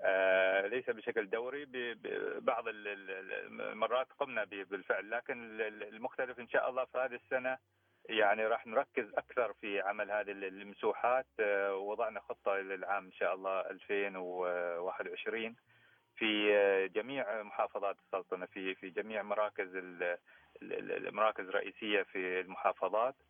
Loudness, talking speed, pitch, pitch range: -36 LUFS, 110 wpm, 100 Hz, 95-115 Hz